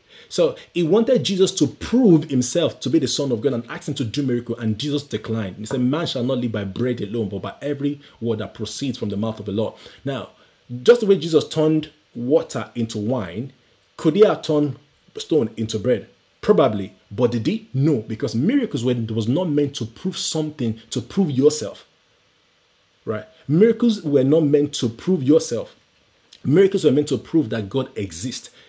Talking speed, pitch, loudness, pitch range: 190 wpm, 140 Hz, -21 LUFS, 115-160 Hz